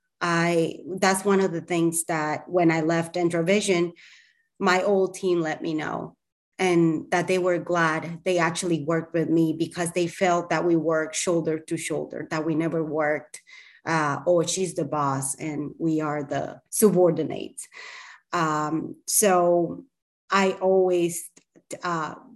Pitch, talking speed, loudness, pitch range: 170 Hz, 150 wpm, -24 LUFS, 160-185 Hz